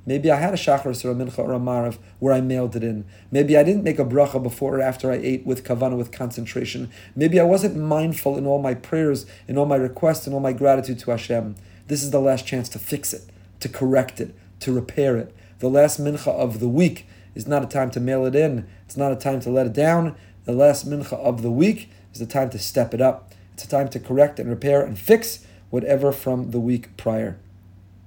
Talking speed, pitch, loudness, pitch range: 235 wpm, 130 Hz, -21 LUFS, 115-140 Hz